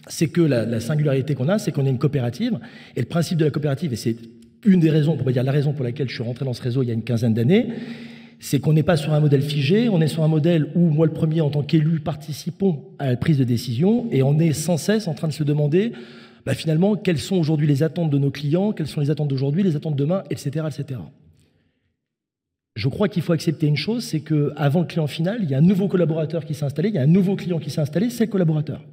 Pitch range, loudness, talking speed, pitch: 140-175 Hz, -21 LUFS, 270 wpm, 155 Hz